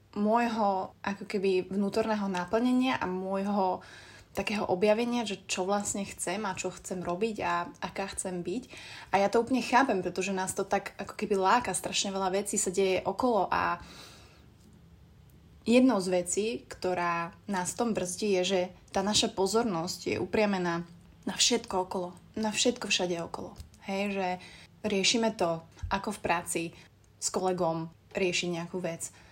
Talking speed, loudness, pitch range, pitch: 150 wpm, -30 LUFS, 180-210 Hz, 195 Hz